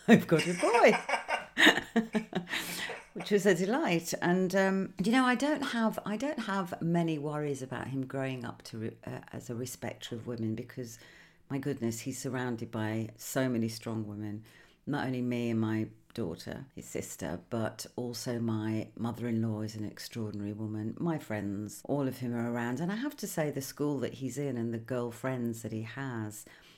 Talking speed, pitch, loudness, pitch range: 180 wpm, 125 Hz, -32 LUFS, 115-170 Hz